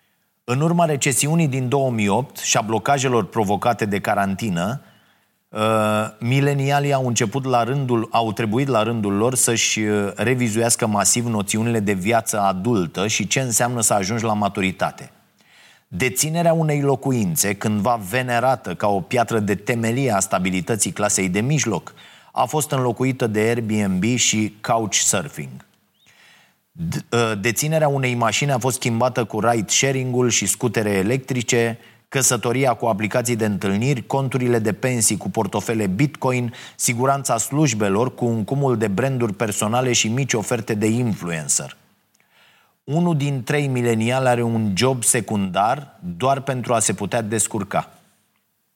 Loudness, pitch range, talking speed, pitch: -20 LUFS, 110-130 Hz, 130 wpm, 120 Hz